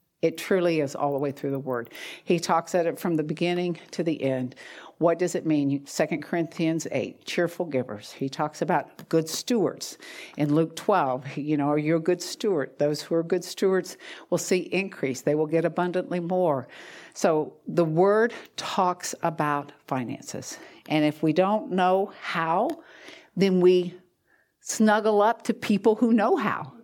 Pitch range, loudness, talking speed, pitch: 150-185 Hz, -26 LUFS, 170 wpm, 170 Hz